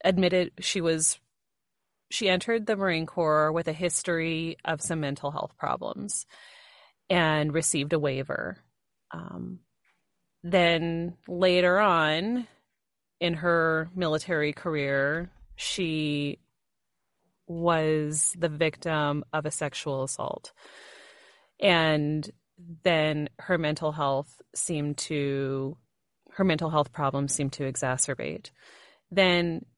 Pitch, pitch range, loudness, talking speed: 160 Hz, 150-175 Hz, -27 LUFS, 105 wpm